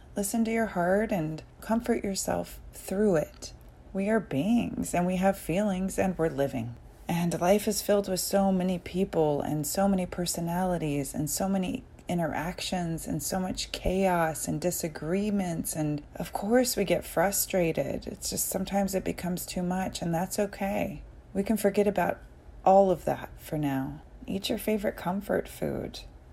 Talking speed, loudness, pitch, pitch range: 160 wpm, -29 LUFS, 185 Hz, 155-200 Hz